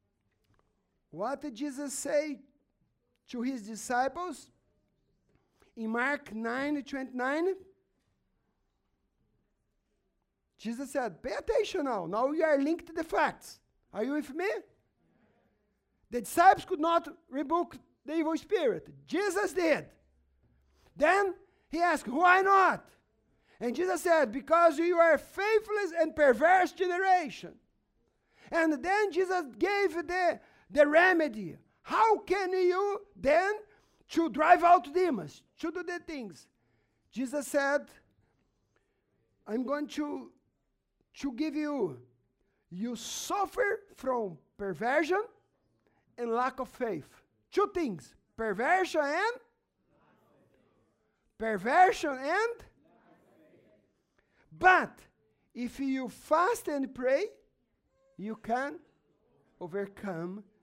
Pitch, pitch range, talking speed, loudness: 300 Hz, 245-360 Hz, 100 wpm, -30 LUFS